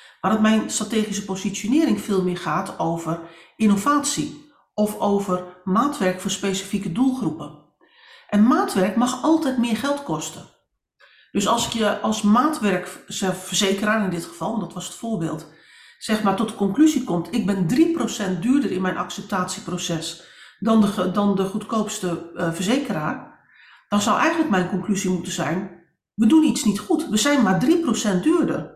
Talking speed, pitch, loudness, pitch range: 150 wpm, 205 Hz, -22 LUFS, 180-235 Hz